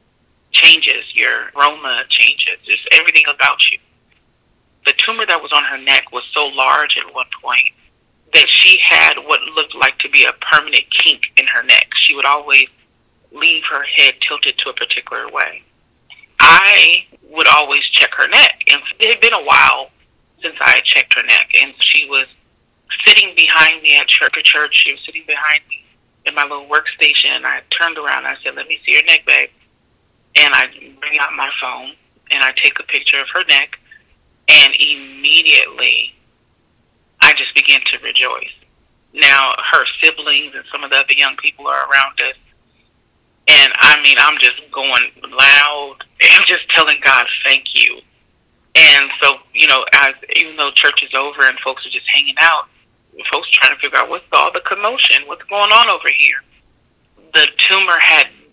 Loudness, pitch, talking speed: -10 LUFS, 205 Hz, 180 wpm